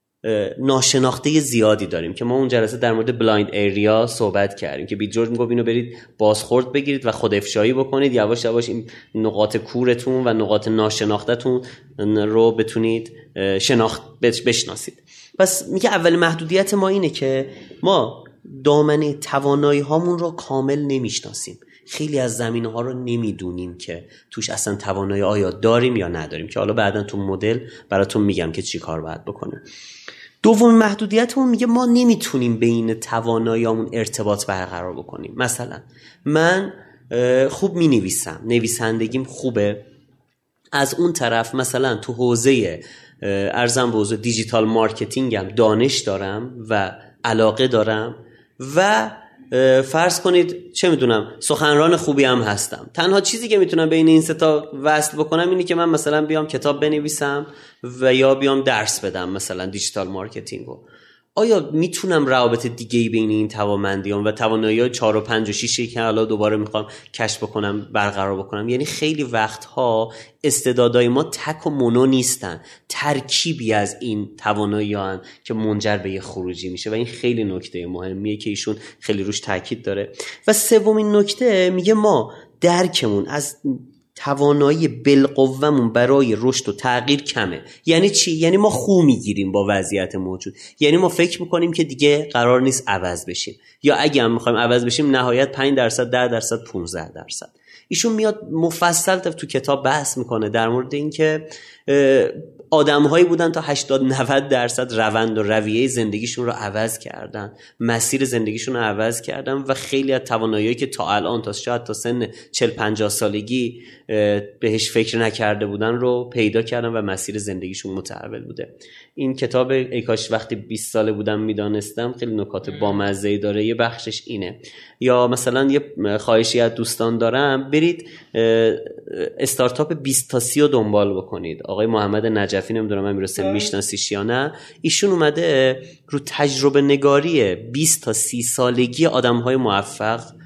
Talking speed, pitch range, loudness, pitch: 150 wpm, 110-145 Hz, -19 LUFS, 120 Hz